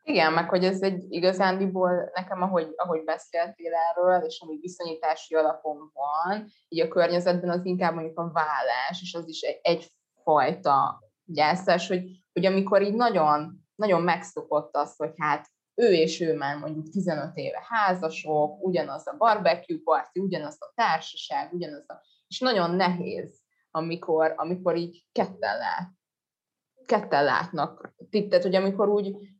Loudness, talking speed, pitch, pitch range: -26 LUFS, 145 wpm, 170 Hz, 160-185 Hz